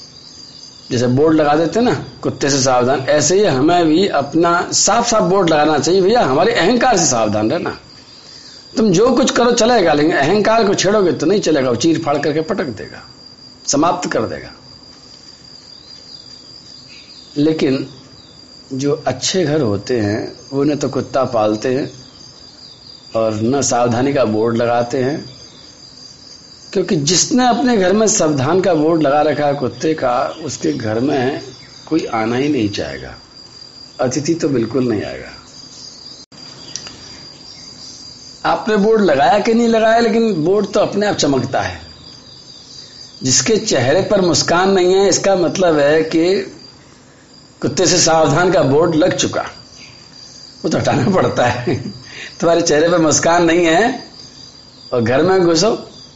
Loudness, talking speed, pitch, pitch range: -14 LUFS, 145 wpm, 155 Hz, 130-190 Hz